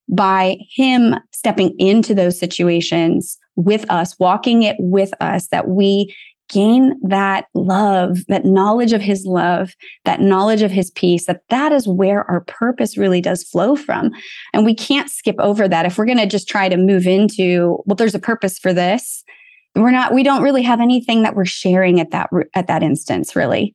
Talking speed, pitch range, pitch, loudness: 185 wpm, 185-225 Hz, 195 Hz, -15 LUFS